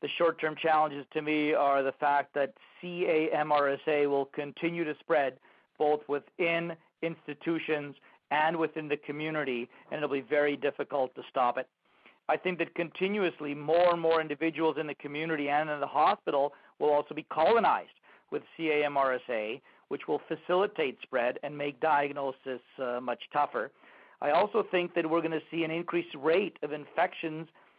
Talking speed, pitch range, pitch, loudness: 160 wpm, 145-165 Hz, 150 Hz, -30 LUFS